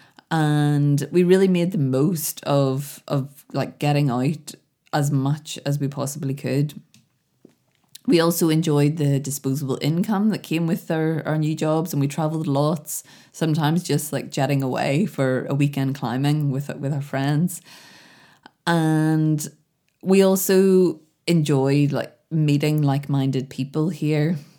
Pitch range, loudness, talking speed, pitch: 140-160 Hz, -22 LUFS, 135 wpm, 150 Hz